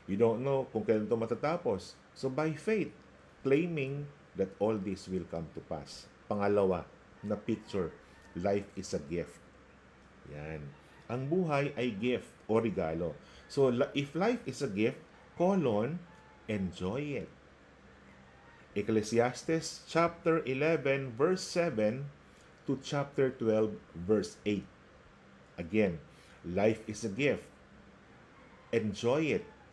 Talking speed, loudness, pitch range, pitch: 115 wpm, -33 LUFS, 85-140 Hz, 110 Hz